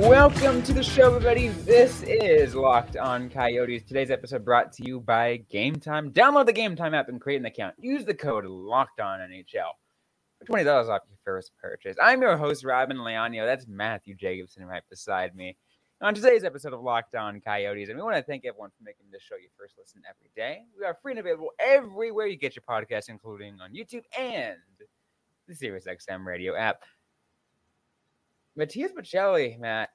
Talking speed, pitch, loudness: 180 wpm, 135 Hz, -25 LUFS